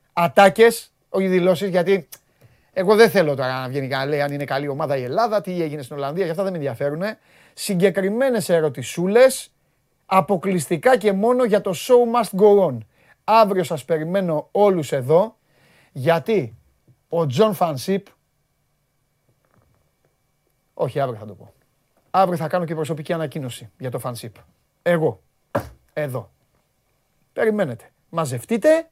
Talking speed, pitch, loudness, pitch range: 135 wpm, 175 Hz, -20 LUFS, 145-200 Hz